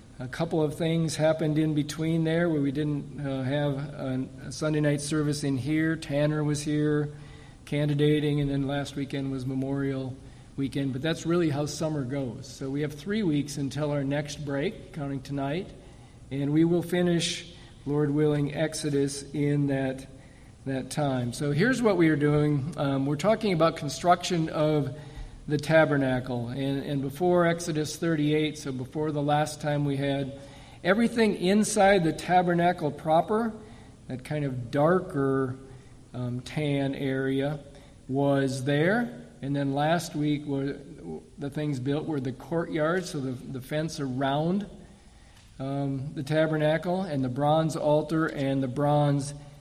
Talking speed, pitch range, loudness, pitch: 150 wpm, 135-155 Hz, -27 LUFS, 145 Hz